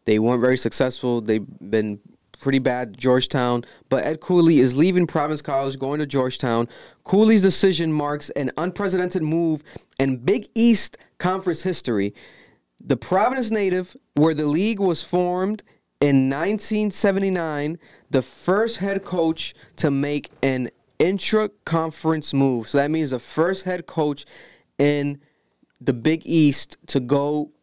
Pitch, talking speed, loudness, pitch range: 155 Hz, 135 wpm, -21 LUFS, 135-180 Hz